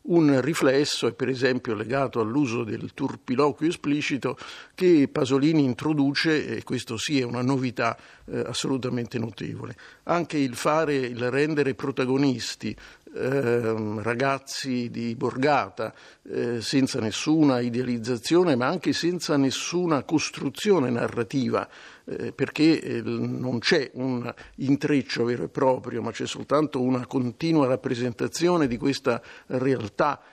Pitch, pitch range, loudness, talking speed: 135 Hz, 120-145 Hz, -25 LUFS, 120 wpm